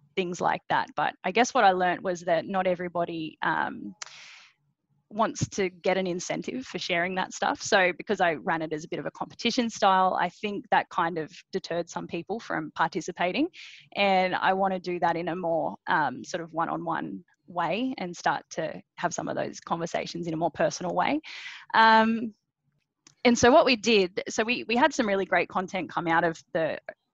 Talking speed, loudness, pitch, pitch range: 205 wpm, -27 LUFS, 185 Hz, 170-220 Hz